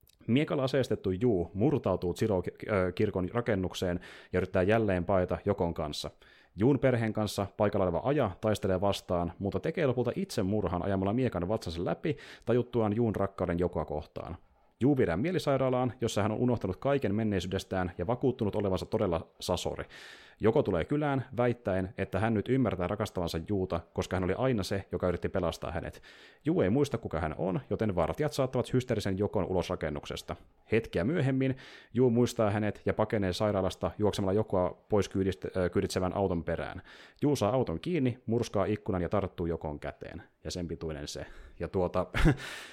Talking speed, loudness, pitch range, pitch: 160 wpm, -31 LUFS, 90-115 Hz, 100 Hz